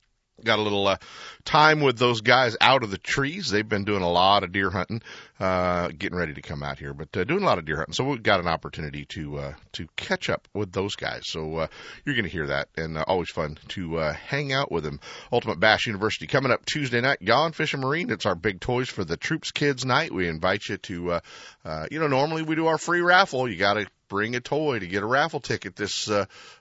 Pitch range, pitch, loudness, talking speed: 90-135 Hz, 105 Hz, -25 LUFS, 255 wpm